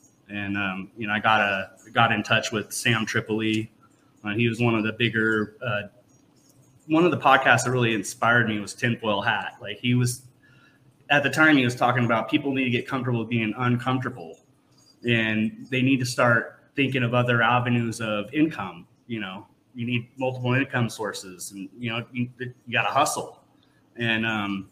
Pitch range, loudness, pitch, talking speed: 110-130 Hz, -24 LUFS, 120 Hz, 190 wpm